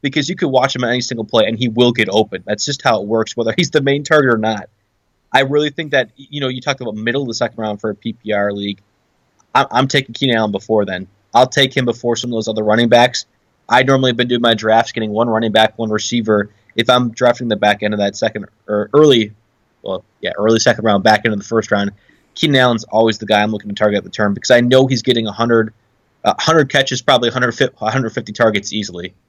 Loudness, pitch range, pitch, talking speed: -15 LUFS, 105-125 Hz, 115 Hz, 245 wpm